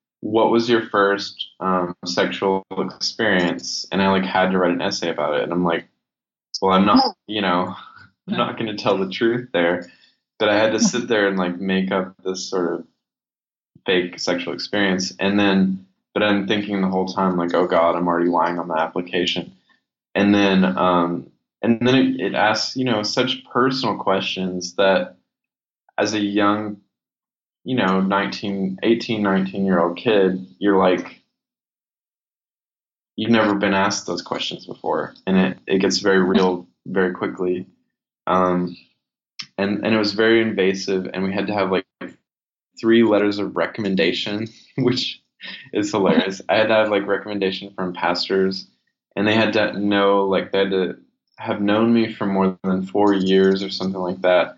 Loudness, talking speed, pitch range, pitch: -20 LUFS, 175 wpm, 95-105 Hz, 95 Hz